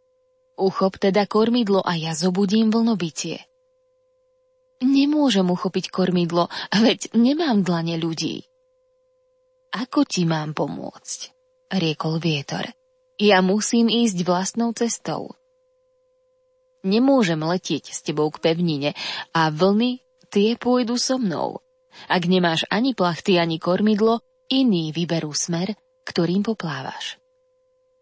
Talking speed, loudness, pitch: 105 wpm, -21 LUFS, 220 Hz